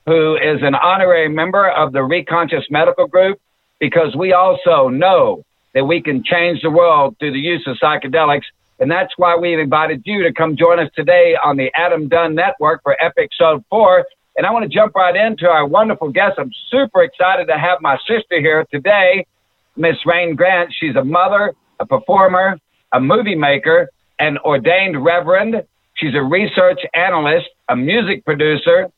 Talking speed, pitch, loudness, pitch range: 175 wpm, 180 Hz, -14 LUFS, 160-215 Hz